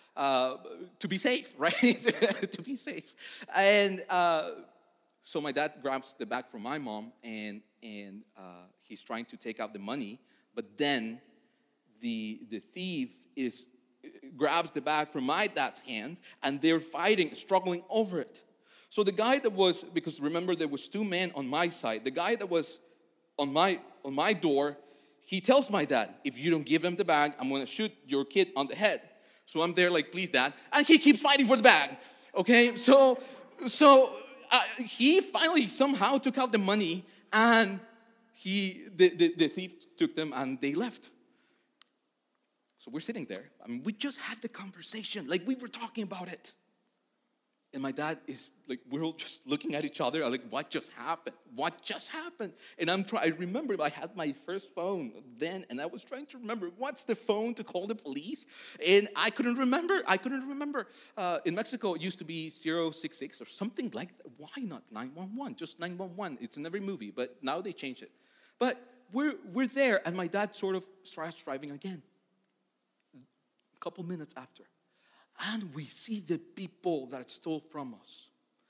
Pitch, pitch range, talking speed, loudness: 190 Hz, 155-240 Hz, 185 wpm, -29 LUFS